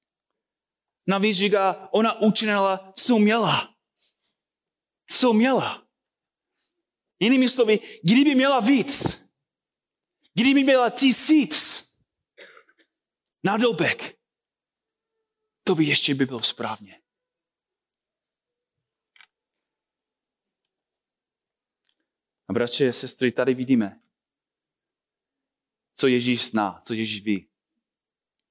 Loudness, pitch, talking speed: -21 LUFS, 205 Hz, 75 wpm